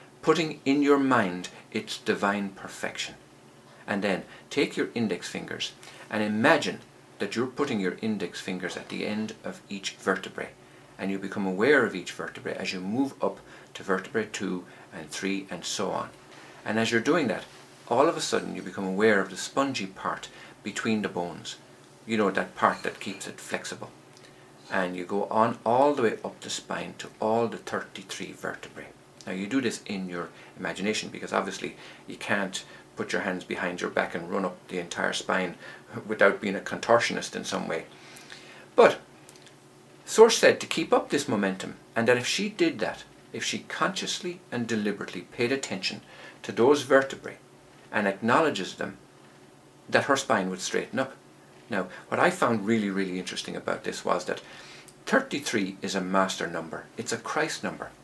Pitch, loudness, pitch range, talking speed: 95 Hz, -28 LUFS, 75-115 Hz, 175 wpm